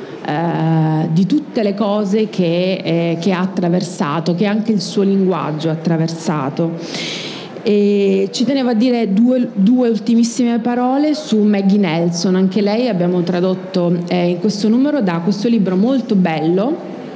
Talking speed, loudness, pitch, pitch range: 145 wpm, -16 LUFS, 195 Hz, 175-220 Hz